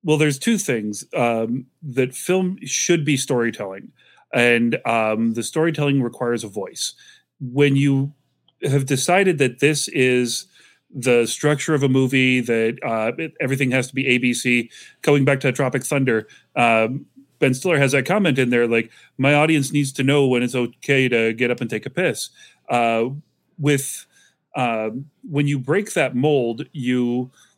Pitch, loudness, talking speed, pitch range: 130 Hz, -20 LUFS, 165 wpm, 120-145 Hz